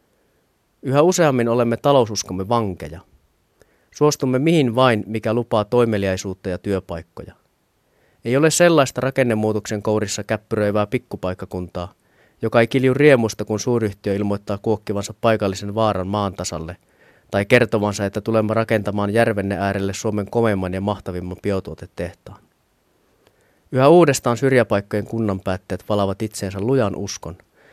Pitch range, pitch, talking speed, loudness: 100-120 Hz, 105 Hz, 115 wpm, -19 LUFS